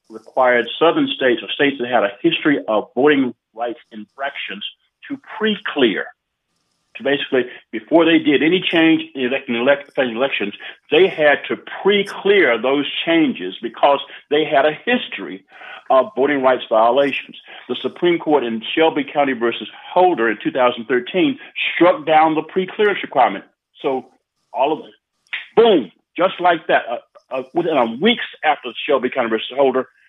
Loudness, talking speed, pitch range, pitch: -17 LUFS, 145 wpm, 130-190 Hz, 155 Hz